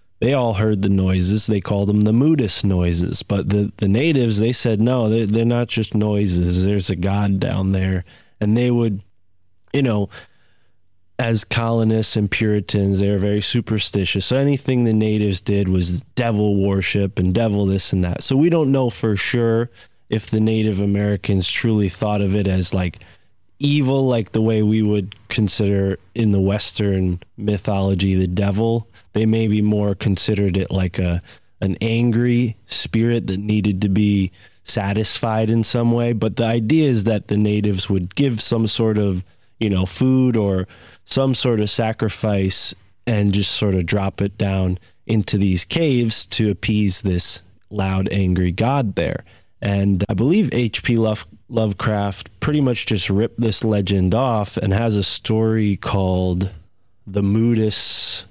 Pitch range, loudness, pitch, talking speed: 95-115 Hz, -19 LUFS, 105 Hz, 165 wpm